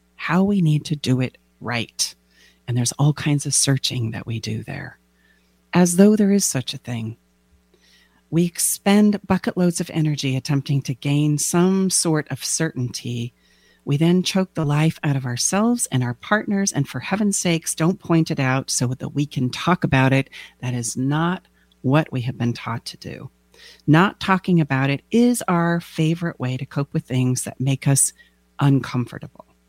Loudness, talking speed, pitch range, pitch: -20 LUFS, 180 wpm, 125-170 Hz, 140 Hz